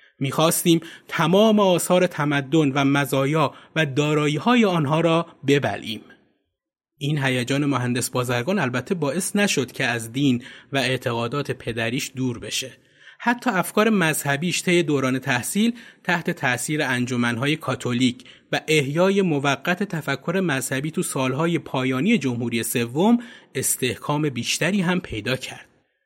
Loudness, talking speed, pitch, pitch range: -22 LUFS, 120 wpm, 145 Hz, 130-175 Hz